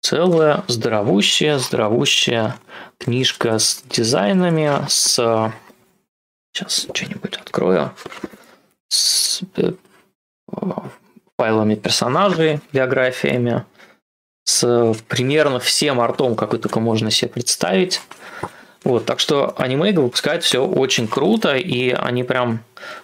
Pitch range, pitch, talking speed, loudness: 115-145 Hz, 125 Hz, 90 wpm, -17 LUFS